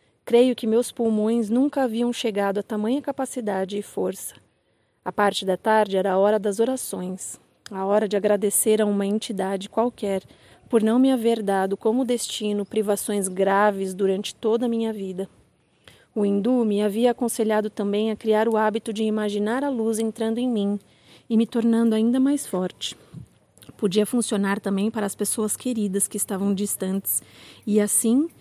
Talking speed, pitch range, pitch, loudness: 165 wpm, 200-230 Hz, 215 Hz, -23 LUFS